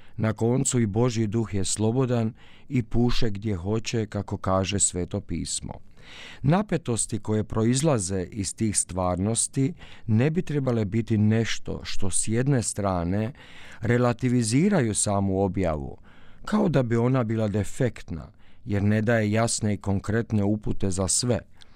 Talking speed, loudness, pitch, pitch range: 130 wpm, -25 LUFS, 110 Hz, 95-120 Hz